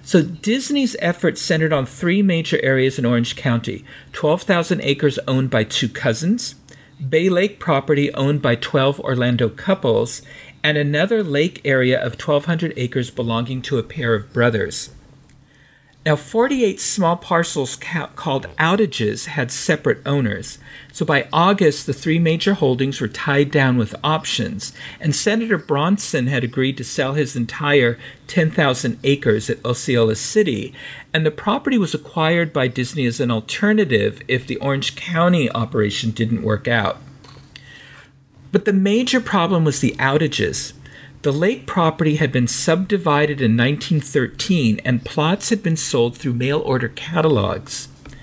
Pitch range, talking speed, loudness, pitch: 130-165 Hz, 145 wpm, -19 LUFS, 140 Hz